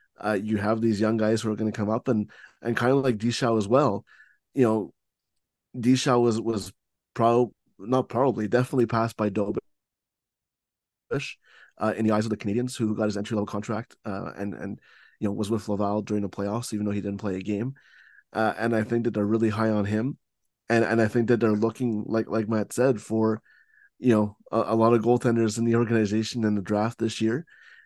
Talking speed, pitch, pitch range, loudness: 215 wpm, 110 Hz, 105-120 Hz, -26 LUFS